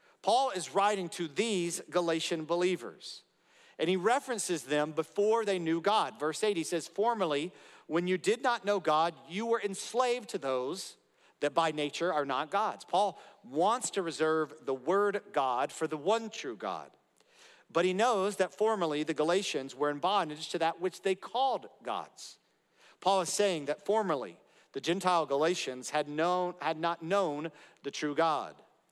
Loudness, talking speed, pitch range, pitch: -32 LUFS, 170 wpm, 160-205 Hz, 180 Hz